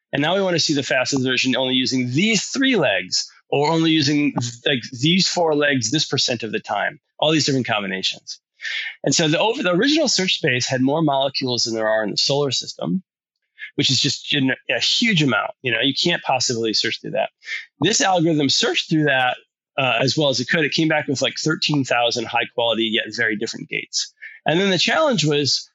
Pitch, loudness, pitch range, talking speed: 145 Hz, -19 LUFS, 125-160 Hz, 210 wpm